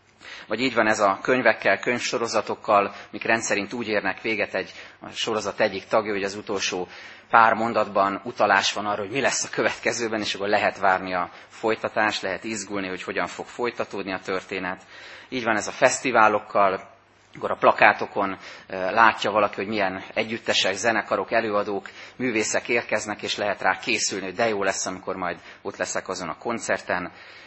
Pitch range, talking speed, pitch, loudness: 95-110 Hz, 165 wpm, 105 Hz, -23 LUFS